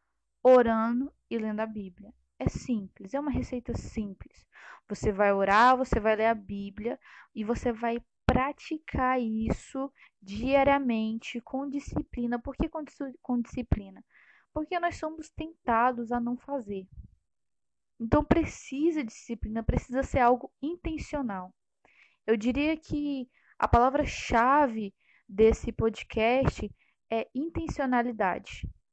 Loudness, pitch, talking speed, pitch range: -29 LUFS, 245 Hz, 115 wpm, 225-280 Hz